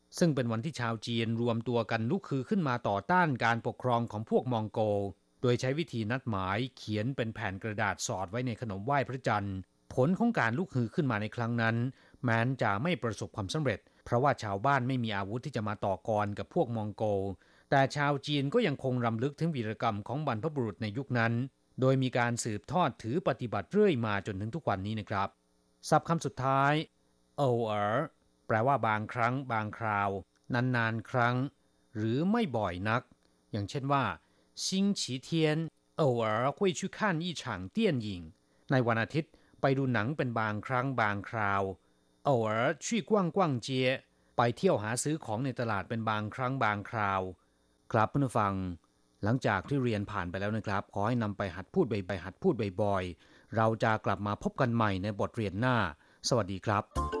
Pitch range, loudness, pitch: 105-135 Hz, -32 LUFS, 115 Hz